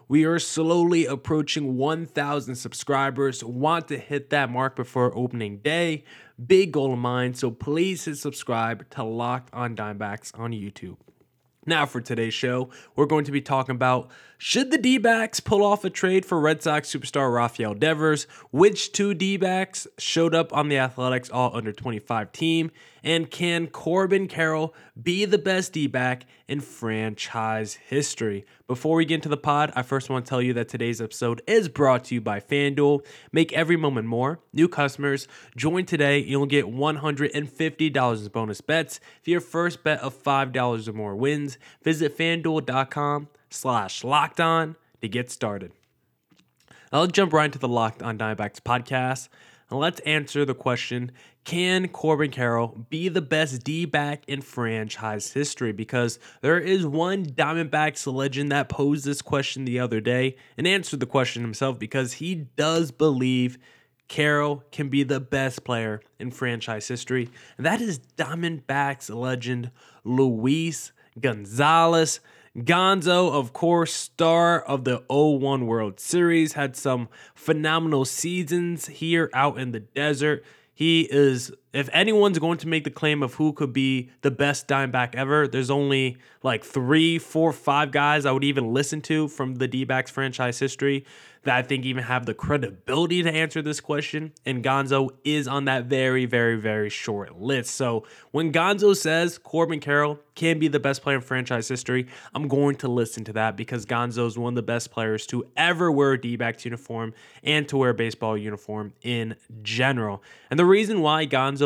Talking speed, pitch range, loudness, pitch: 165 wpm, 125-155 Hz, -24 LUFS, 140 Hz